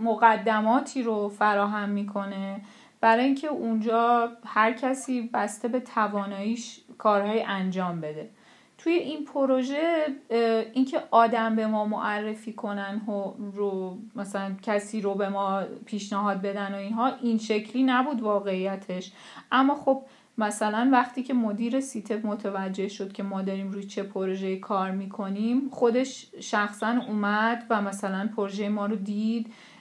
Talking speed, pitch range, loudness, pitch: 130 wpm, 200-235 Hz, -27 LUFS, 215 Hz